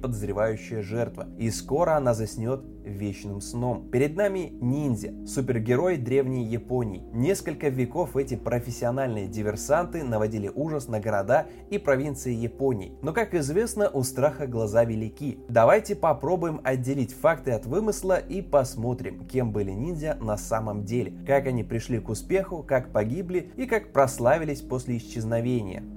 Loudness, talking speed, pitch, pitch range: -27 LUFS, 135 wpm, 125 Hz, 110-145 Hz